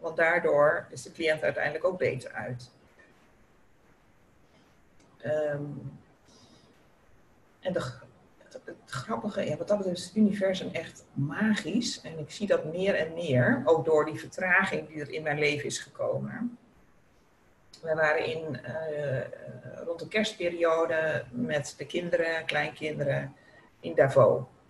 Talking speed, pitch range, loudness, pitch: 135 wpm, 150-175 Hz, -29 LUFS, 160 Hz